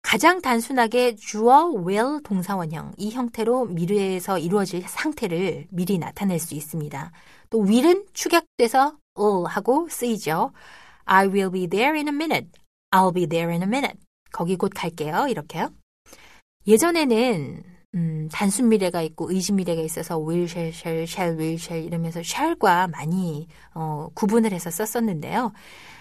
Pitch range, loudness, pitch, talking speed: 170-235 Hz, -23 LUFS, 190 Hz, 420 characters per minute